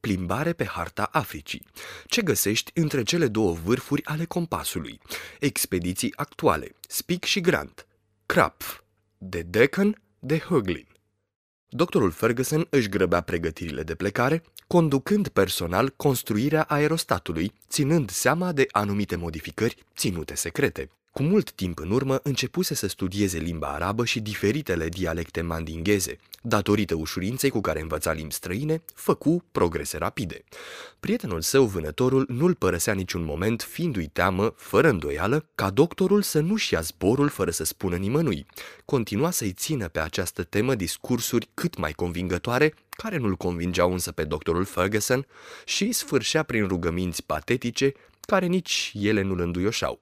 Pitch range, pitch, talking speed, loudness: 90-150 Hz, 110 Hz, 135 wpm, -25 LUFS